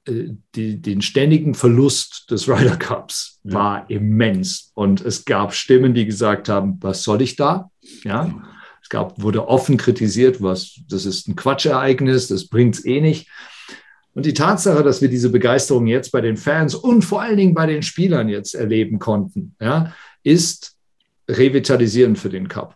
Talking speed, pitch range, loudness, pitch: 165 wpm, 105-150 Hz, -17 LUFS, 125 Hz